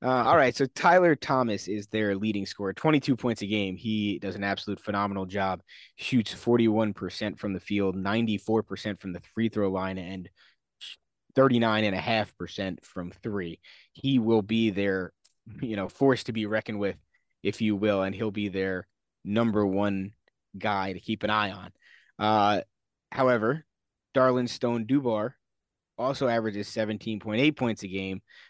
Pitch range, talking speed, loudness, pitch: 95-115 Hz, 150 wpm, -27 LUFS, 105 Hz